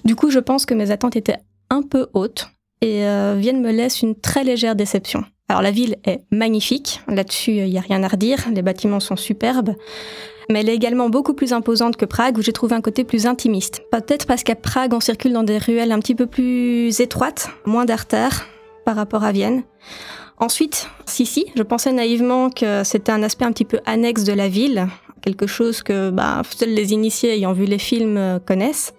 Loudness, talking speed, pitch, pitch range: -19 LUFS, 210 wpm, 230 Hz, 210-245 Hz